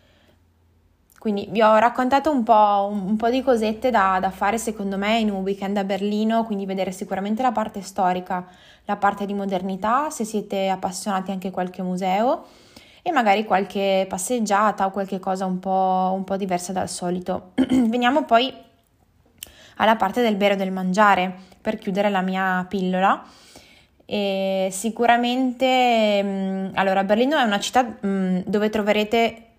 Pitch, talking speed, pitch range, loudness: 200 Hz, 150 wpm, 190-220 Hz, -21 LUFS